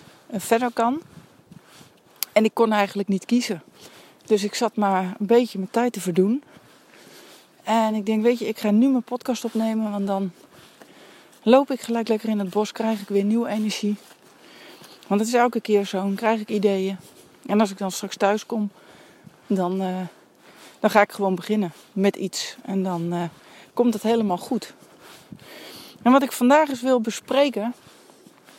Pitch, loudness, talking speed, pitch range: 215 Hz, -23 LUFS, 175 wpm, 200-235 Hz